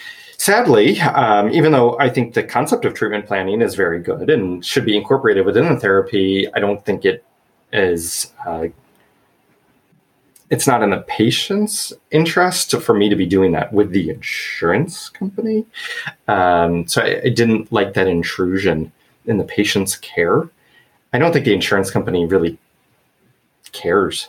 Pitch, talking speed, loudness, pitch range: 105 Hz, 155 wpm, -17 LUFS, 95-145 Hz